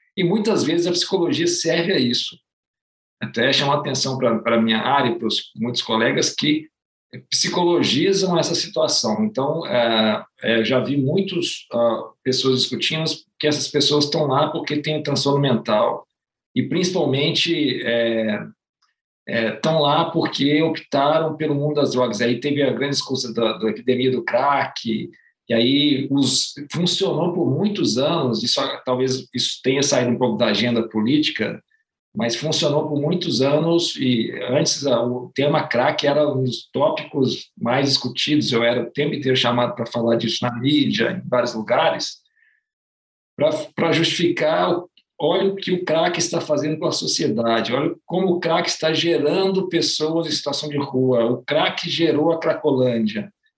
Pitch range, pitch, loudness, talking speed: 125-170 Hz, 145 Hz, -20 LUFS, 155 wpm